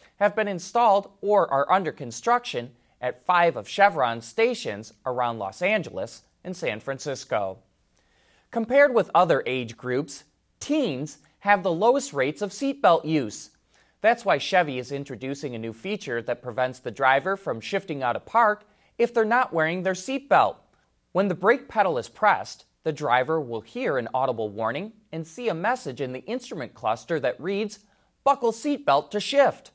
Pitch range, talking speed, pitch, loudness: 130-210 Hz, 165 wpm, 160 Hz, -25 LUFS